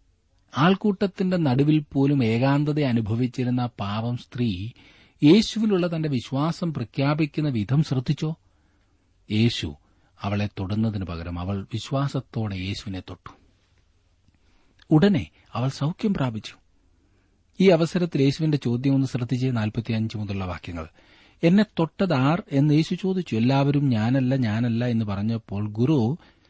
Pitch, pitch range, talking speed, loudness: 120 Hz, 100-150 Hz, 100 wpm, -24 LUFS